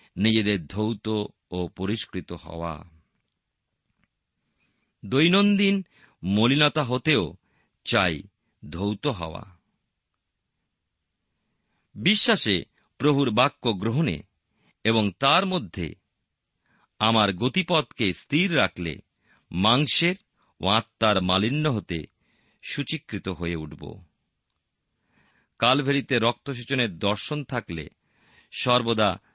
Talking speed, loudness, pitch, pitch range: 70 wpm, -24 LUFS, 110 Hz, 95-140 Hz